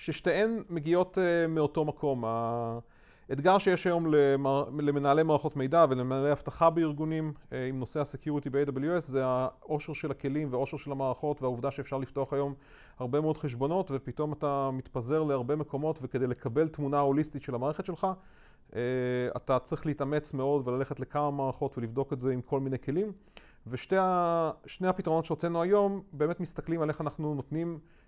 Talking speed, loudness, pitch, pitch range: 145 wpm, -30 LUFS, 145 Hz, 135-160 Hz